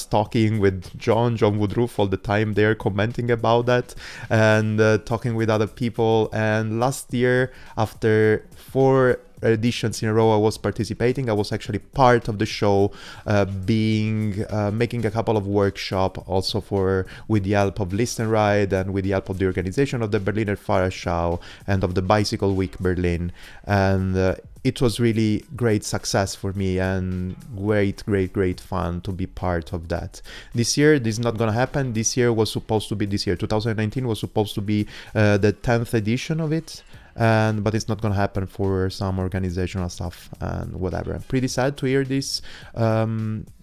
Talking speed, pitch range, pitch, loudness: 185 wpm, 95-115 Hz, 110 Hz, -22 LUFS